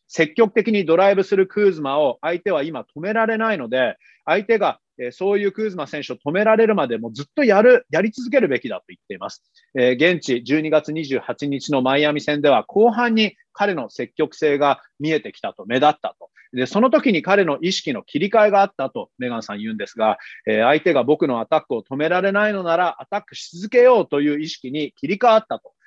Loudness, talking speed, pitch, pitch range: -19 LUFS, 400 characters per minute, 175 Hz, 145-215 Hz